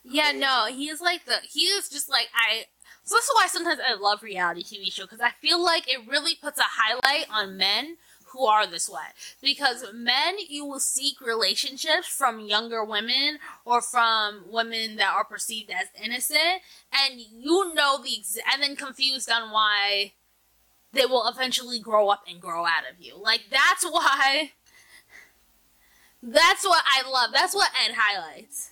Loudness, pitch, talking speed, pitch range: -23 LUFS, 255 Hz, 175 wpm, 215-300 Hz